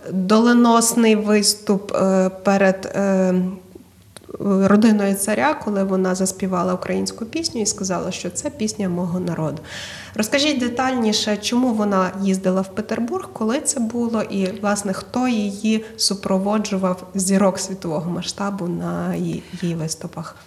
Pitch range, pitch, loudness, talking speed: 185-220 Hz, 195 Hz, -20 LUFS, 110 wpm